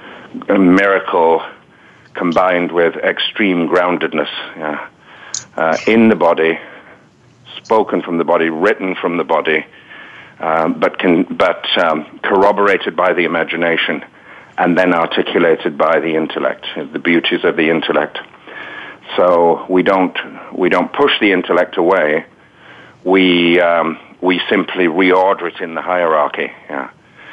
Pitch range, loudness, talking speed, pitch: 85-95 Hz, -14 LUFS, 125 wpm, 90 Hz